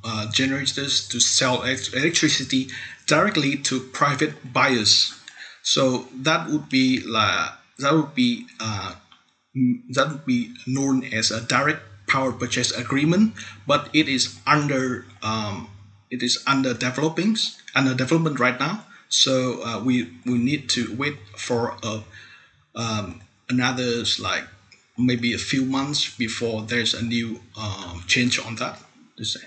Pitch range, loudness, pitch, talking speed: 115-135 Hz, -22 LUFS, 125 Hz, 135 wpm